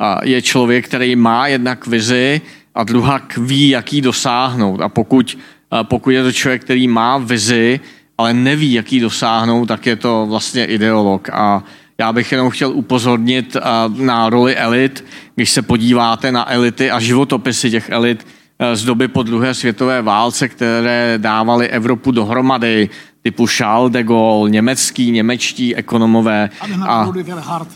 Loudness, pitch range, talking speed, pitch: -14 LUFS, 115-130 Hz, 140 wpm, 120 Hz